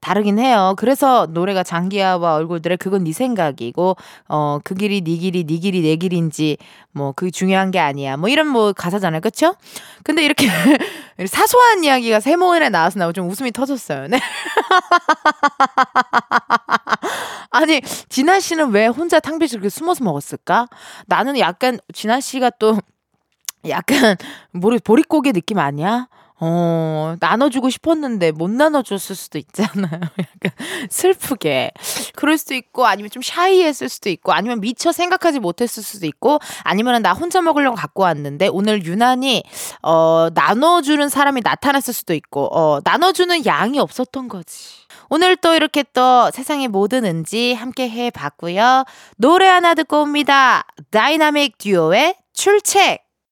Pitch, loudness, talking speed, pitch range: 235 Hz, -16 LUFS, 310 characters per minute, 180-295 Hz